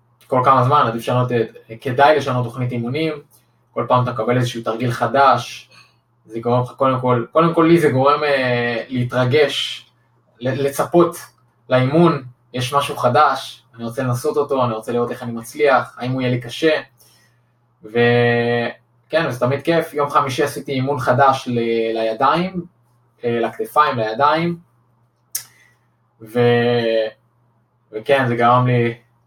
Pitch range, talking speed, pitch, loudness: 120-140 Hz, 135 wpm, 125 Hz, -18 LUFS